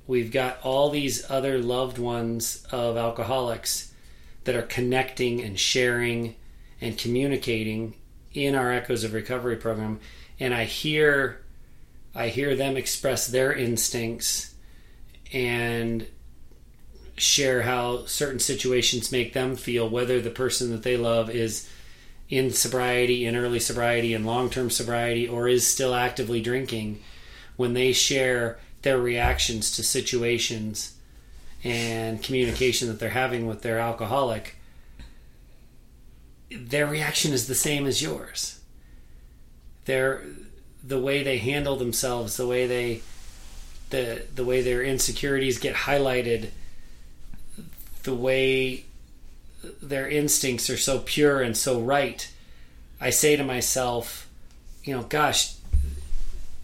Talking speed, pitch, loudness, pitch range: 120 wpm, 120 Hz, -25 LUFS, 105-130 Hz